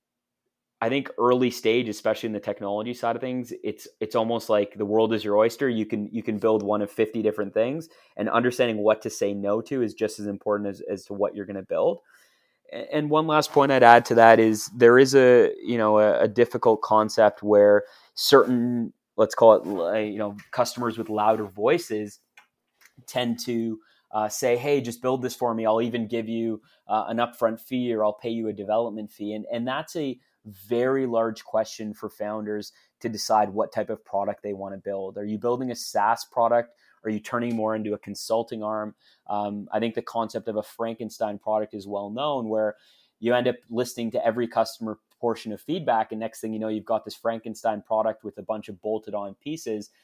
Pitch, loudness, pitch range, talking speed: 110 Hz, -24 LUFS, 105-120 Hz, 210 wpm